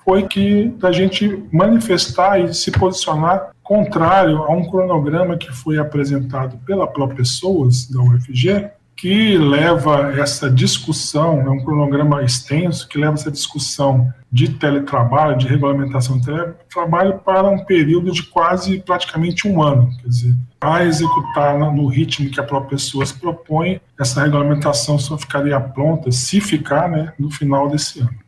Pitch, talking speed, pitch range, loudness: 150 Hz, 145 wpm, 140-175 Hz, -16 LUFS